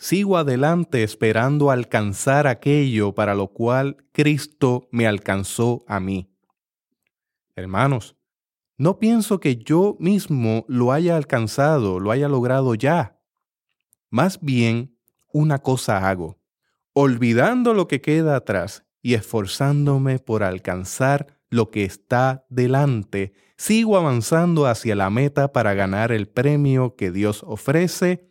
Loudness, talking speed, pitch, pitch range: -20 LUFS, 120 wpm, 130 Hz, 110-145 Hz